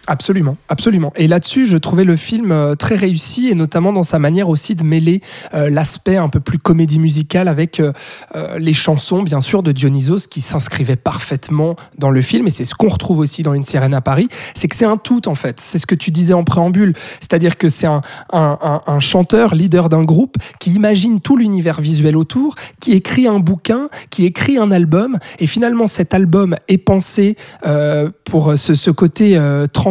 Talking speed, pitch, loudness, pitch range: 205 wpm, 170 Hz, -14 LUFS, 150-195 Hz